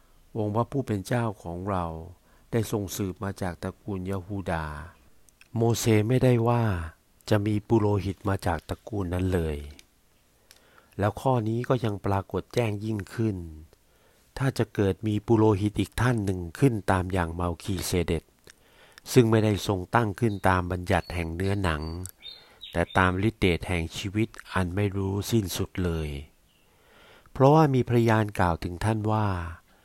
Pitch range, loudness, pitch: 90-110 Hz, -27 LUFS, 100 Hz